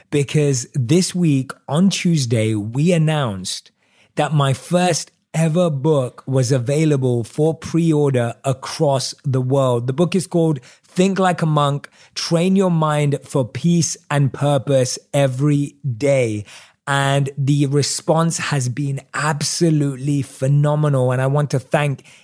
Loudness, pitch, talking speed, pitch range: -18 LUFS, 145 Hz, 130 wpm, 135-160 Hz